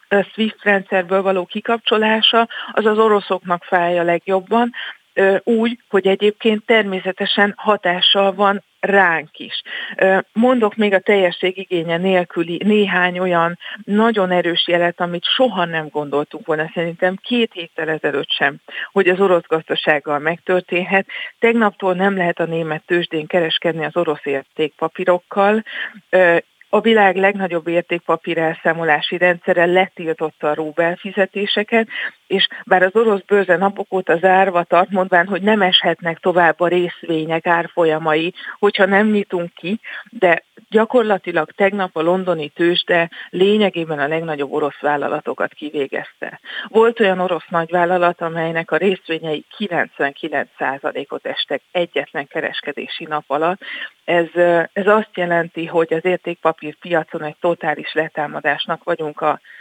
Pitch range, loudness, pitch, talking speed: 165-200 Hz, -17 LUFS, 180 Hz, 125 wpm